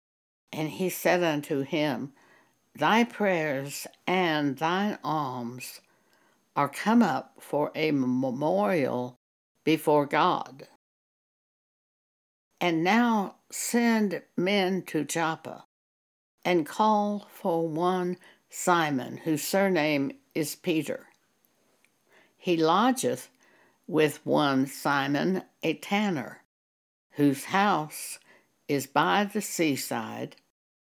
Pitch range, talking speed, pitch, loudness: 145-190 Hz, 90 wpm, 160 Hz, -27 LUFS